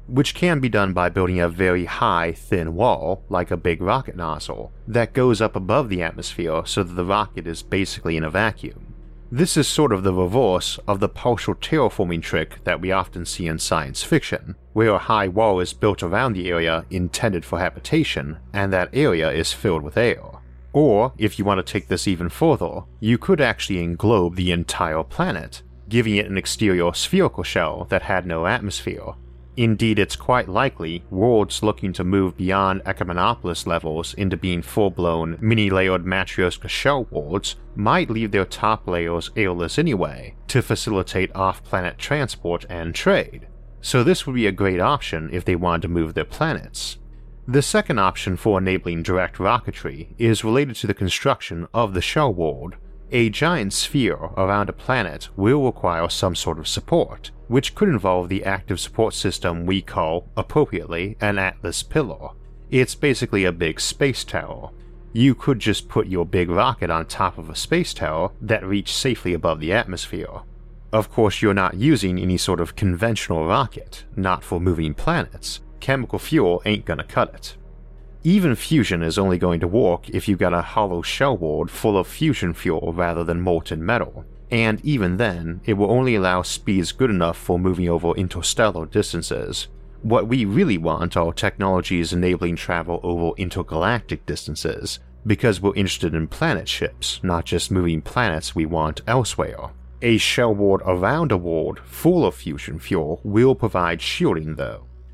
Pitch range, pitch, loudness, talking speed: 85-110 Hz, 95 Hz, -21 LUFS, 170 wpm